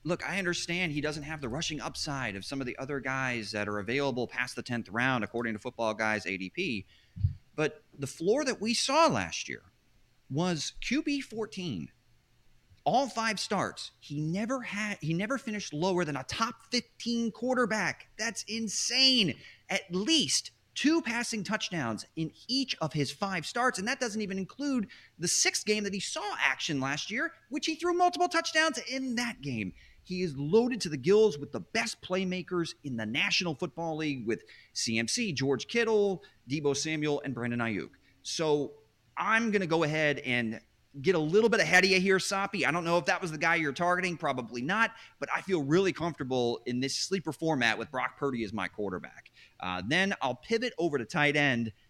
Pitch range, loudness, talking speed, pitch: 135-220 Hz, -30 LUFS, 185 wpm, 170 Hz